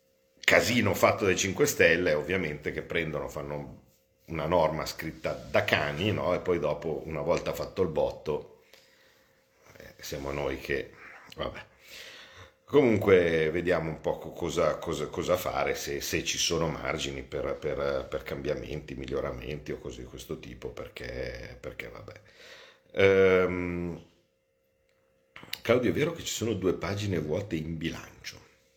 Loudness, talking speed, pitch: -29 LUFS, 135 wpm, 90 Hz